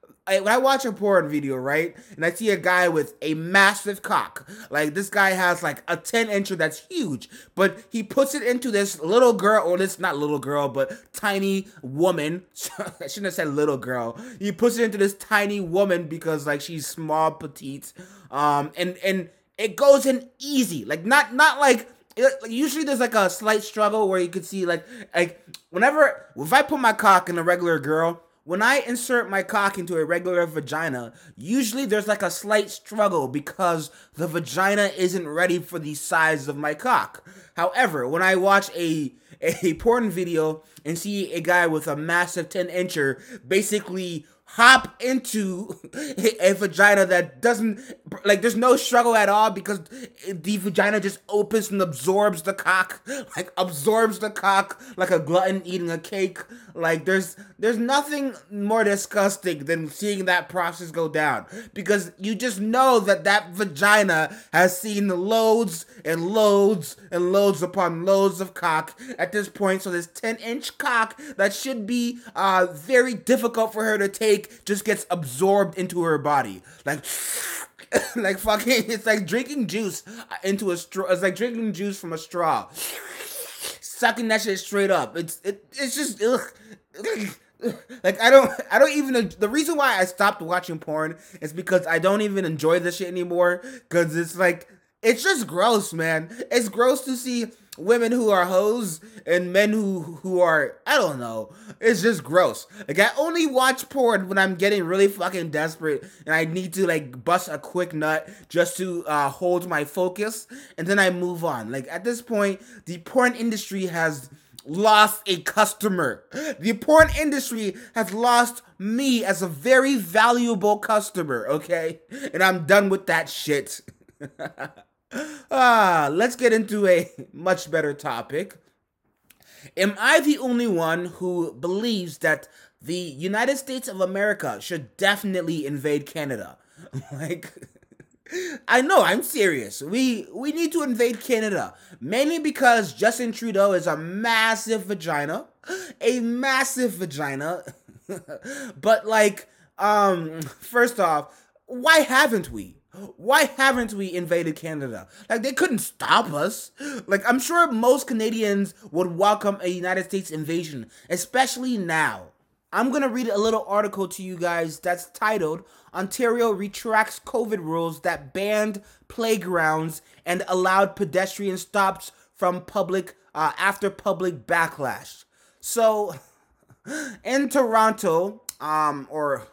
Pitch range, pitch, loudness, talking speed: 175-230 Hz, 195 Hz, -22 LUFS, 160 wpm